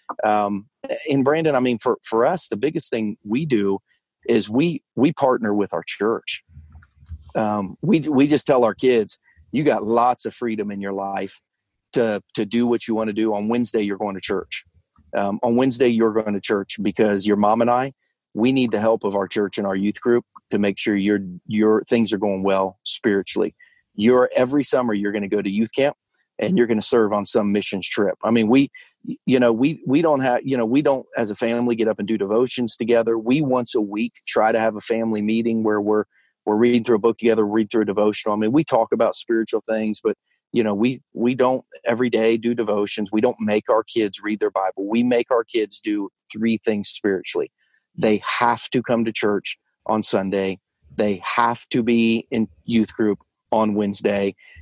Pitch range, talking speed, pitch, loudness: 105-120 Hz, 215 wpm, 110 Hz, -21 LUFS